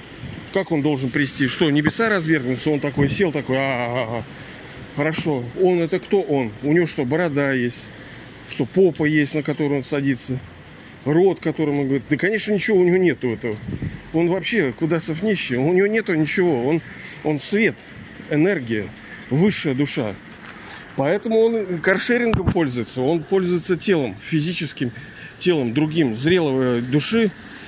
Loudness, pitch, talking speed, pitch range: -20 LUFS, 150 Hz, 145 wpm, 130-180 Hz